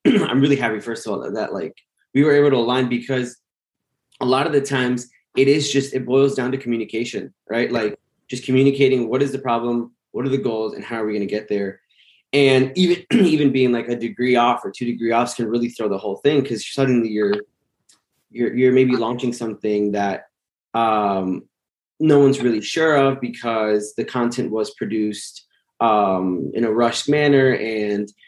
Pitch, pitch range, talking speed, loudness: 120 Hz, 110-135 Hz, 195 wpm, -19 LUFS